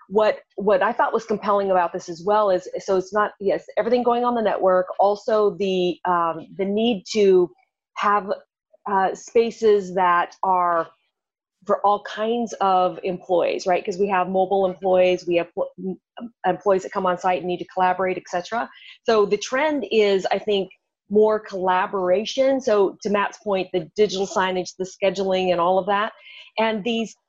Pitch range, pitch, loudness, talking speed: 185-215 Hz, 195 Hz, -21 LUFS, 170 wpm